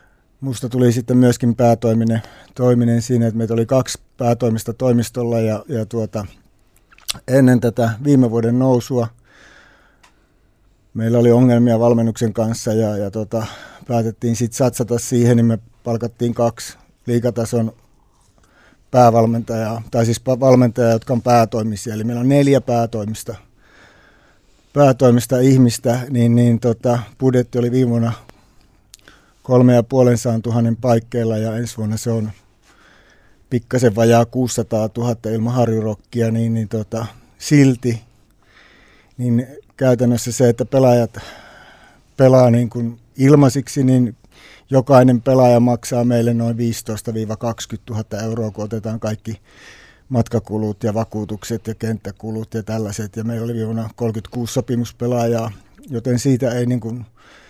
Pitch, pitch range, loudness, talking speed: 115 Hz, 110-125 Hz, -17 LUFS, 120 wpm